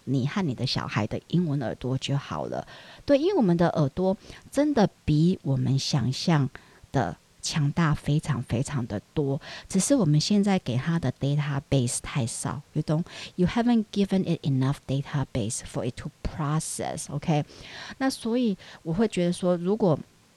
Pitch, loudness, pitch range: 150 Hz, -27 LUFS, 135-185 Hz